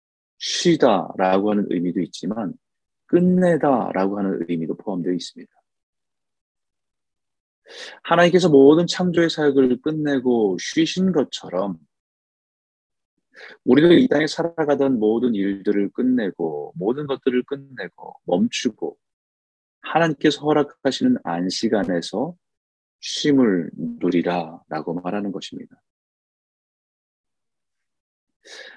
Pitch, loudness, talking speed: 125 Hz, -20 LUFS, 225 characters per minute